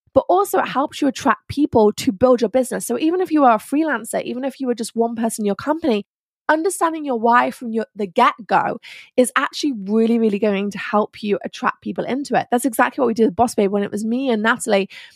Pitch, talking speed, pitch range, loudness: 240 Hz, 245 wpm, 220-270 Hz, -19 LUFS